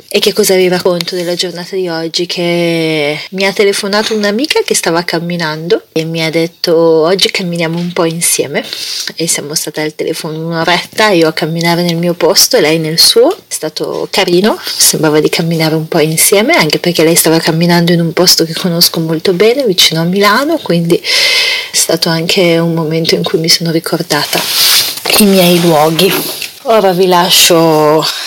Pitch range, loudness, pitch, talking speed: 165-195 Hz, -9 LUFS, 175 Hz, 175 wpm